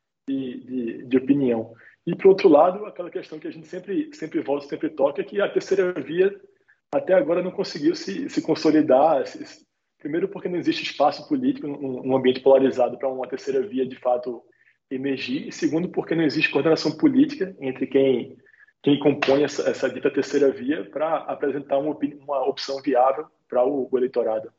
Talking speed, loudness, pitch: 185 wpm, -23 LUFS, 155 Hz